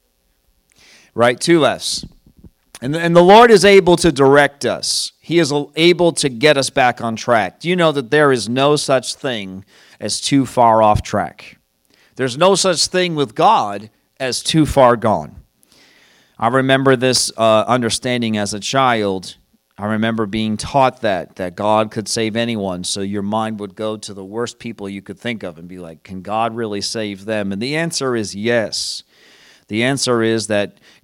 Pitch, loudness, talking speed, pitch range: 115 Hz, -16 LUFS, 180 wpm, 105-140 Hz